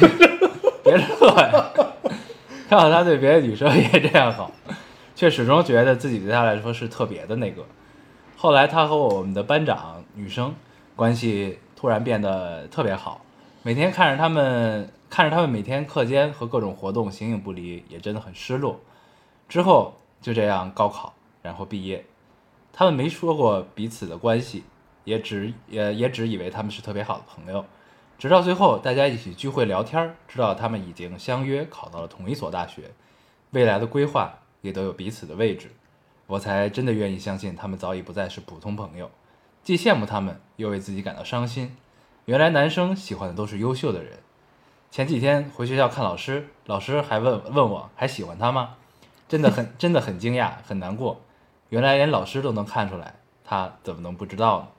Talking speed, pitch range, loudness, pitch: 280 characters per minute, 100-145 Hz, -22 LUFS, 115 Hz